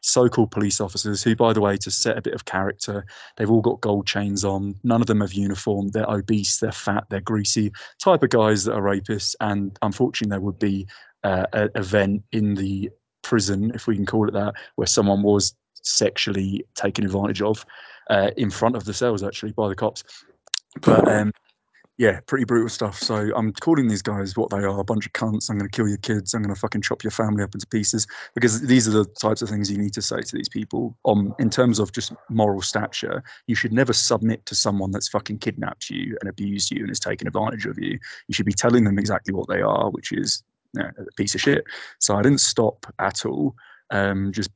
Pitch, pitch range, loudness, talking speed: 105 Hz, 100-115 Hz, -22 LUFS, 225 wpm